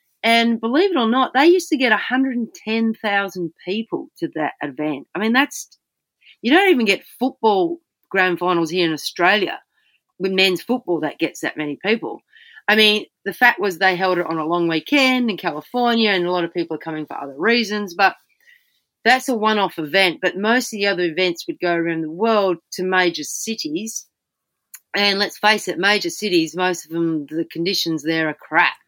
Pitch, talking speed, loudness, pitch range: 200 Hz, 195 wpm, -19 LUFS, 170-235 Hz